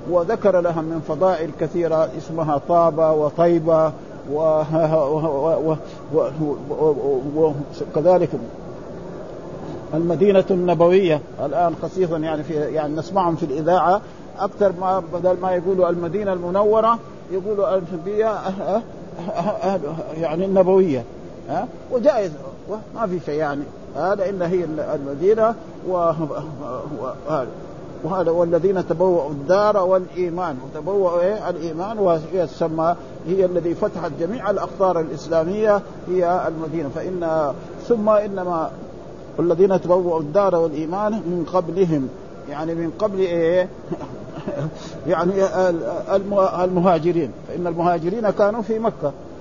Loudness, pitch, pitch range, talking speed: -20 LUFS, 175 Hz, 165-190 Hz, 110 wpm